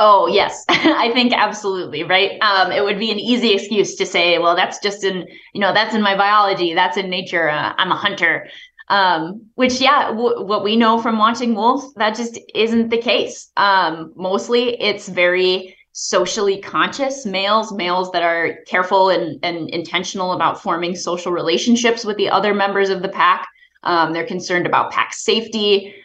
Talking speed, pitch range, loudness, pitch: 180 wpm, 180-225 Hz, -17 LUFS, 200 Hz